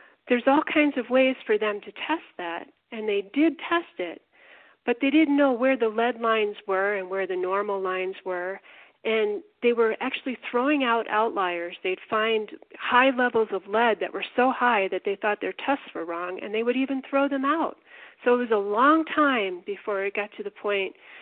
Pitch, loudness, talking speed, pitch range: 225 Hz, -25 LUFS, 205 wpm, 200-270 Hz